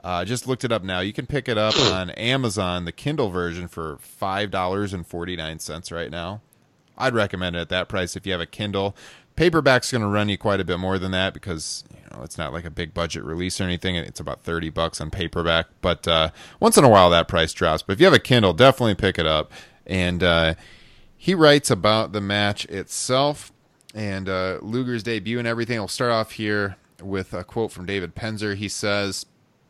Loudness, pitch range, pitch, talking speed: -22 LUFS, 85-110 Hz, 95 Hz, 225 wpm